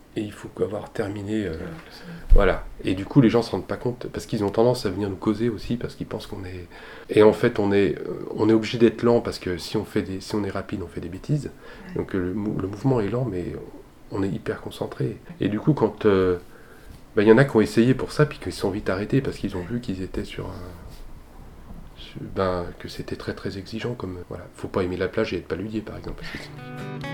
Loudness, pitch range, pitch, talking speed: -24 LUFS, 95-120 Hz, 105 Hz, 250 wpm